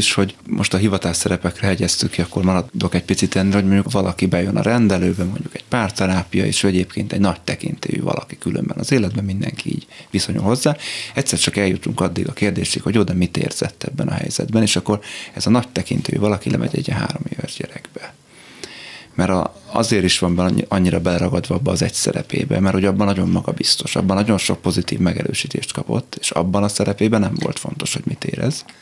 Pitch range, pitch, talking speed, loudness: 90-105 Hz, 95 Hz, 190 wpm, -19 LUFS